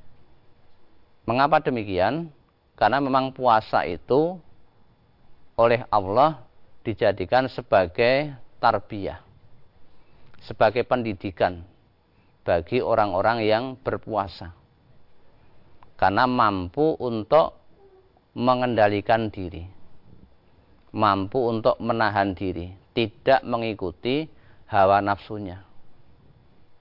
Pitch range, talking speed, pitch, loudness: 100-125 Hz, 65 wpm, 110 Hz, -23 LUFS